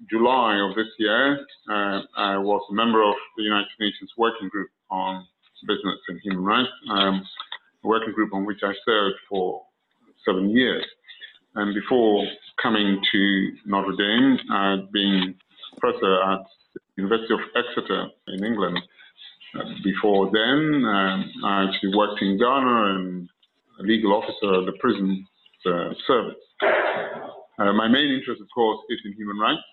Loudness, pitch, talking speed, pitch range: -23 LUFS, 100 Hz, 145 wpm, 95-110 Hz